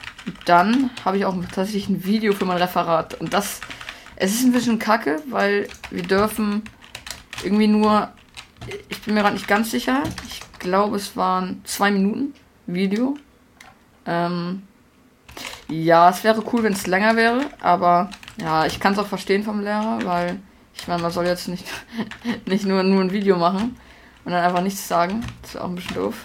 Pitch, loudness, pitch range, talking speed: 200 Hz, -21 LUFS, 180-220 Hz, 180 wpm